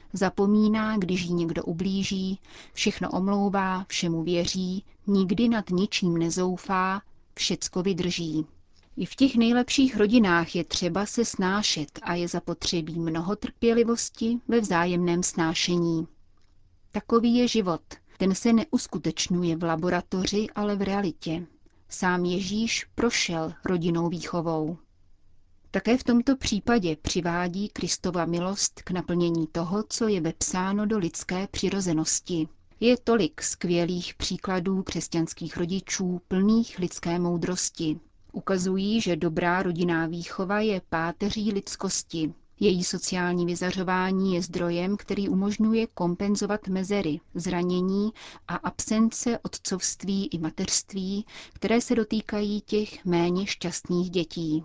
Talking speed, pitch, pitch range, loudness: 115 wpm, 185 Hz, 170-205 Hz, -26 LUFS